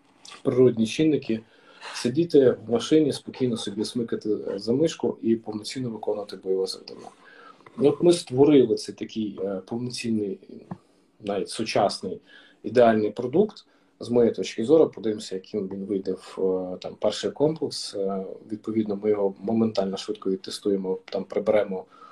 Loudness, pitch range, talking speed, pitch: -25 LUFS, 100-125 Hz, 120 wpm, 110 Hz